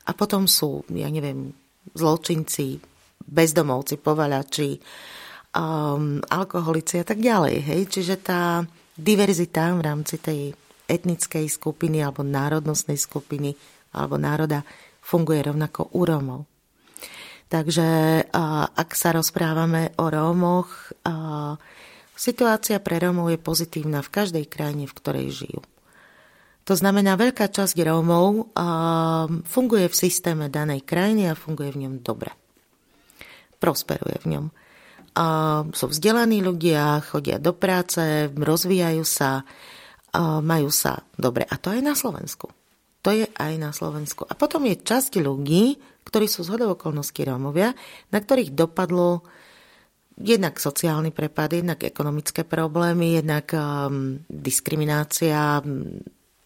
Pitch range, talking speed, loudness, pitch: 150-180 Hz, 120 wpm, -23 LUFS, 165 Hz